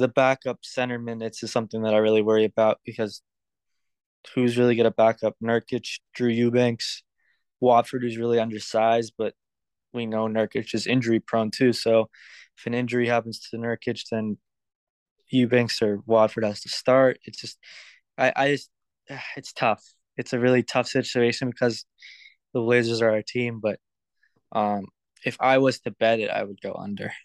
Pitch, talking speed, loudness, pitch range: 115 Hz, 165 wpm, -24 LUFS, 110-125 Hz